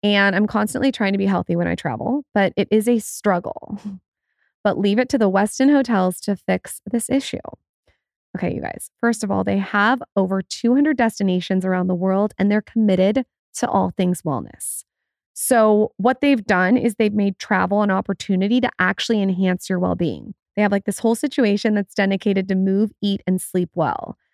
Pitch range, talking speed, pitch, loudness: 190-230 Hz, 190 wpm, 205 Hz, -20 LUFS